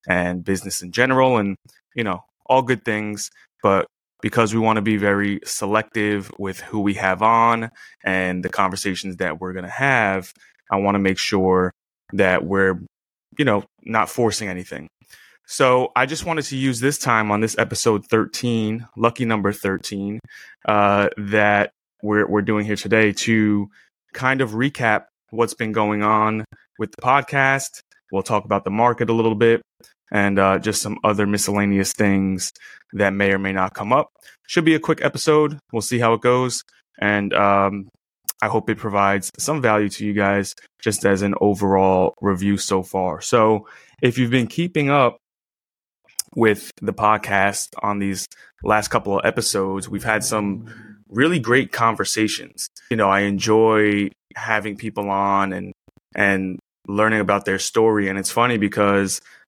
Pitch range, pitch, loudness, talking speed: 100-115 Hz, 105 Hz, -20 LUFS, 165 wpm